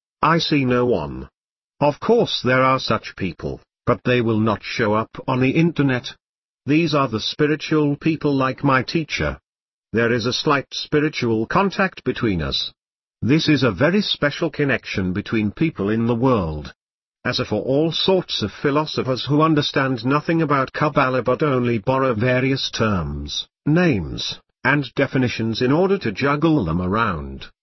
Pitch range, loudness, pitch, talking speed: 115-150 Hz, -20 LUFS, 130 Hz, 155 wpm